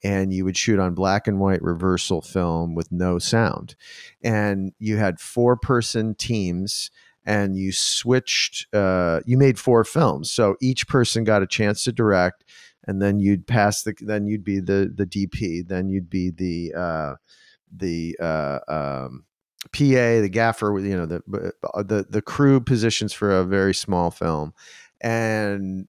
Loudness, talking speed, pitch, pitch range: -22 LUFS, 160 wpm, 100 Hz, 90-110 Hz